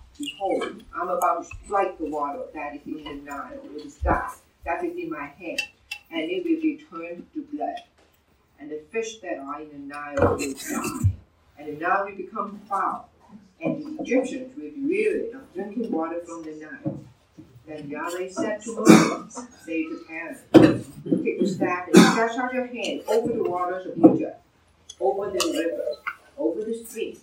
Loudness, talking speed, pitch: -25 LUFS, 185 wpm, 200 Hz